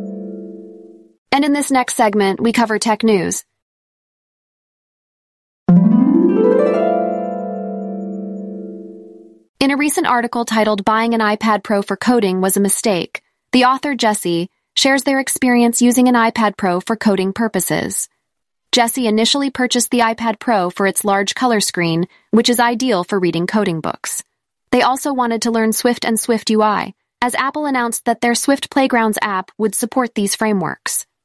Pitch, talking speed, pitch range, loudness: 225 Hz, 145 wpm, 200-245 Hz, -16 LUFS